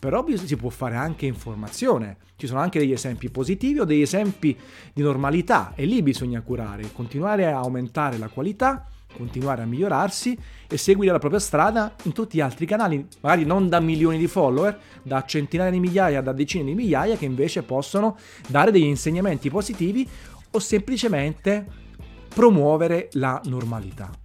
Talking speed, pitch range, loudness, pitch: 160 wpm, 130-195 Hz, -23 LUFS, 155 Hz